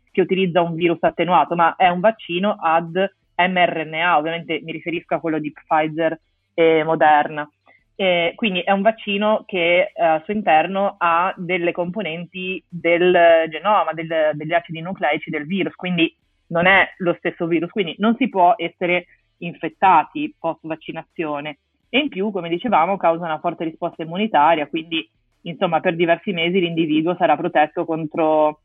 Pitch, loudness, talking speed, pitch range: 170 Hz, -19 LUFS, 155 wpm, 160-185 Hz